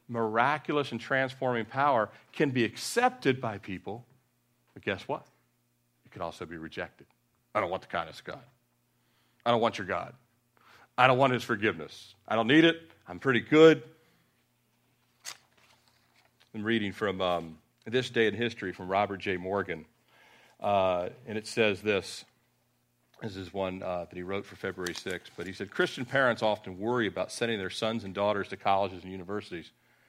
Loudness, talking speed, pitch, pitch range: -29 LUFS, 170 wpm, 110 Hz, 95-120 Hz